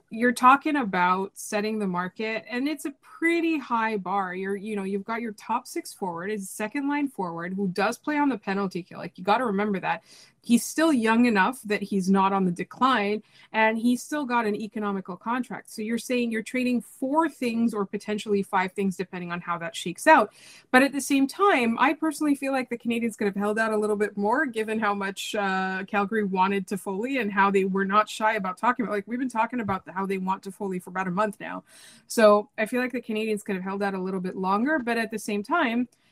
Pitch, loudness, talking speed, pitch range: 215 Hz, -26 LUFS, 240 wpm, 195-245 Hz